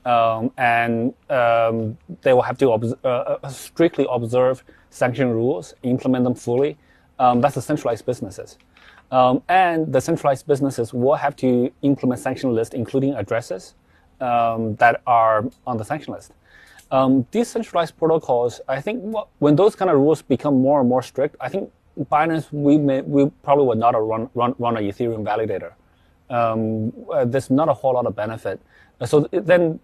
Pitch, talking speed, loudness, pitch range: 130 Hz, 170 wpm, -20 LUFS, 120-145 Hz